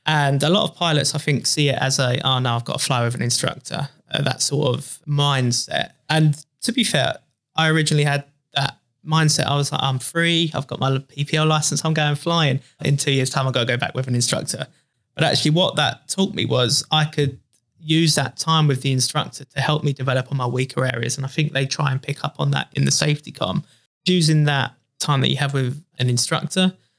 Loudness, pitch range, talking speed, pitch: -20 LUFS, 130-155 Hz, 235 wpm, 145 Hz